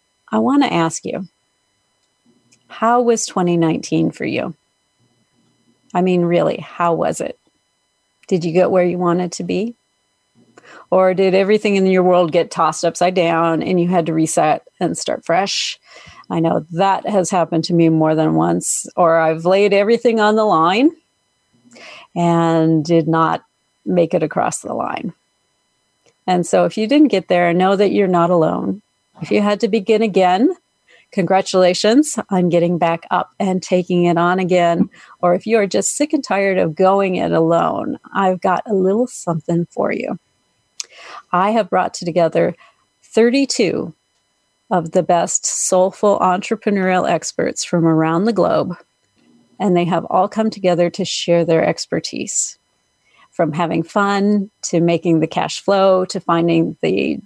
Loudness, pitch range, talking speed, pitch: -16 LUFS, 170-200 Hz, 155 wpm, 180 Hz